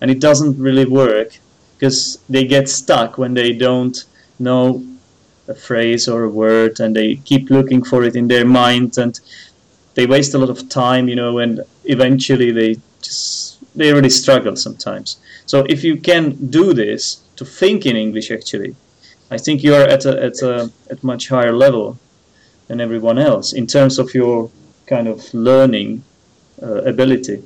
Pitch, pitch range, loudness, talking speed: 125 Hz, 120-135 Hz, -14 LUFS, 175 wpm